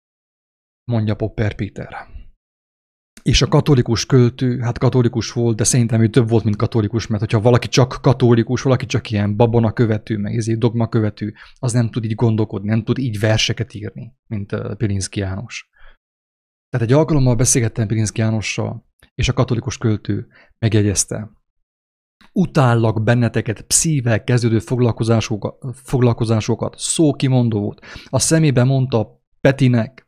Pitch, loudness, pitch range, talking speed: 115 Hz, -17 LUFS, 110-125 Hz, 135 wpm